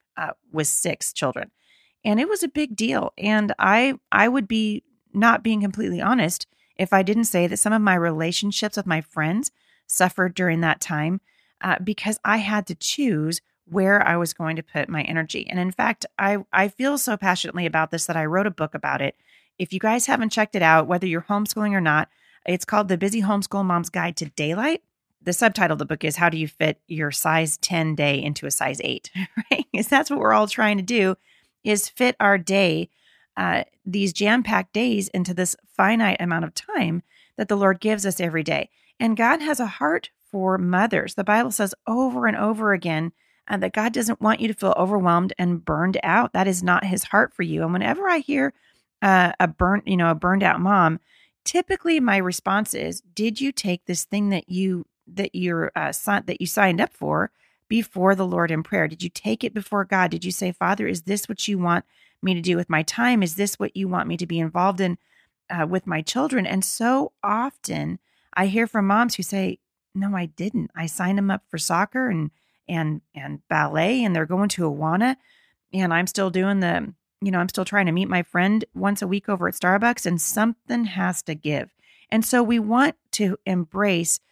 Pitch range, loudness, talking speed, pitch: 175-215 Hz, -22 LUFS, 215 wpm, 195 Hz